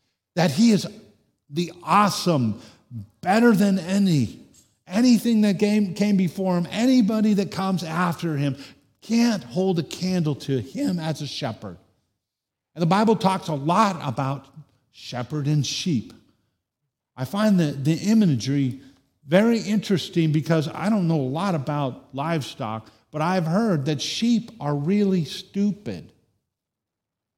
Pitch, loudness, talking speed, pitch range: 165 Hz, -22 LUFS, 130 wpm, 135-200 Hz